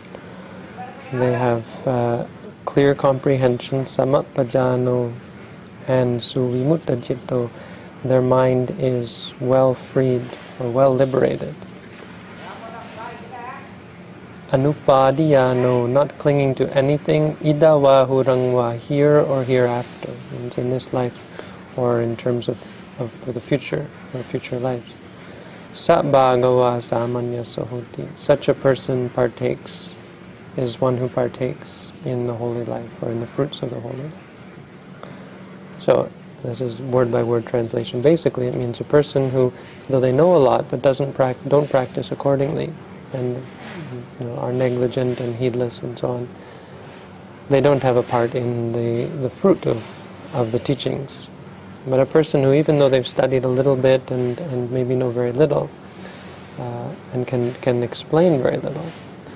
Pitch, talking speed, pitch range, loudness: 130 Hz, 135 wpm, 120-135 Hz, -20 LUFS